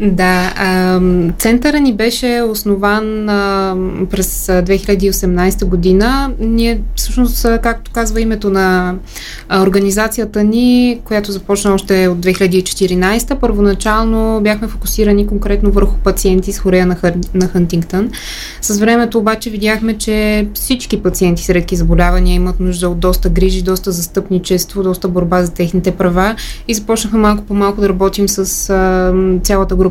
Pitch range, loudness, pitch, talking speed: 185-220 Hz, -13 LUFS, 195 Hz, 125 wpm